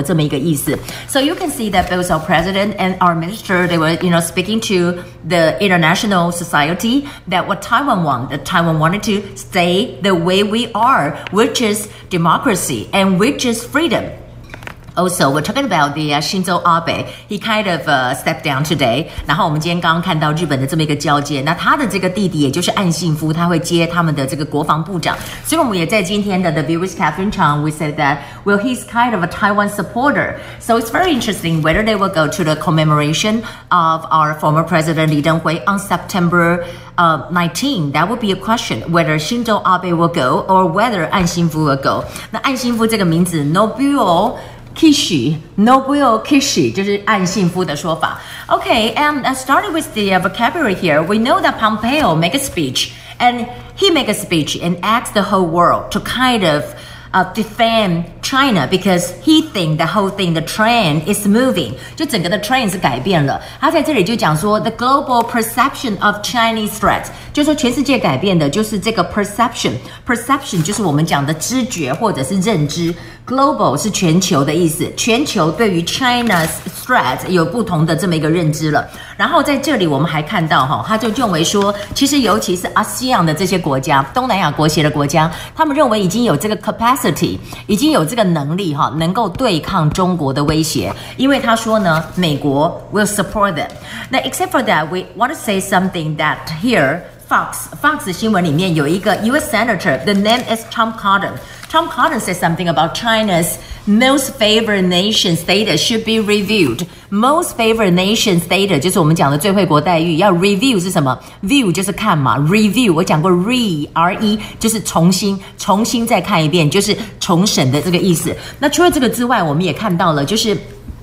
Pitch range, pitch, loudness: 165-225 Hz, 185 Hz, -14 LUFS